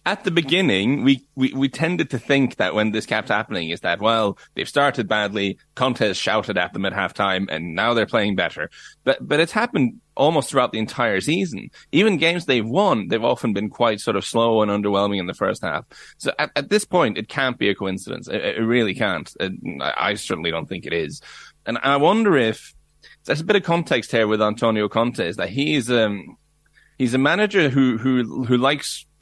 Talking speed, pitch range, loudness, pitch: 210 wpm, 110-150 Hz, -21 LUFS, 125 Hz